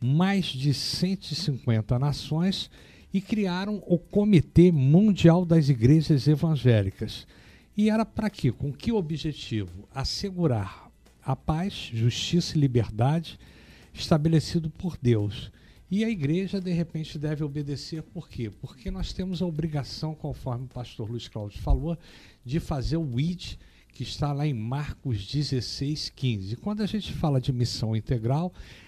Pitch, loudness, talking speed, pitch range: 145 Hz, -27 LUFS, 135 wpm, 120-170 Hz